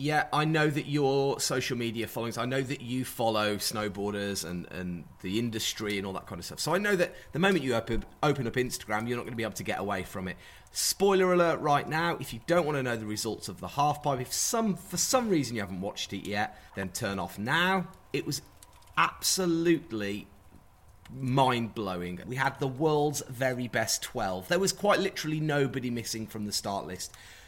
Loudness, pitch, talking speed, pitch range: -30 LUFS, 125 Hz, 210 wpm, 105-150 Hz